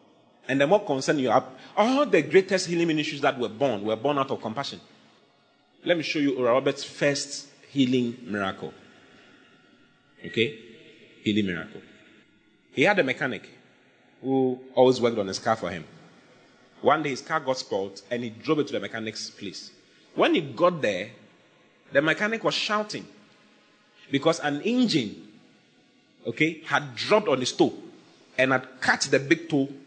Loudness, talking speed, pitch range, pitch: -25 LUFS, 160 wpm, 120-160 Hz, 140 Hz